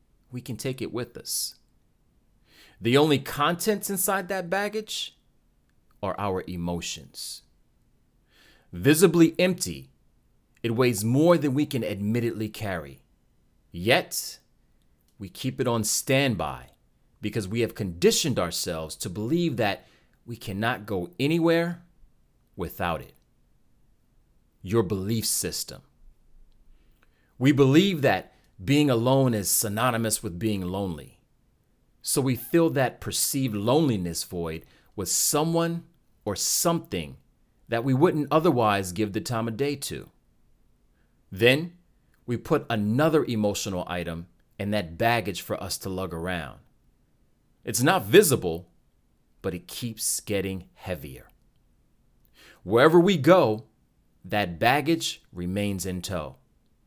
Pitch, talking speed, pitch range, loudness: 115 Hz, 115 wpm, 95-145 Hz, -25 LUFS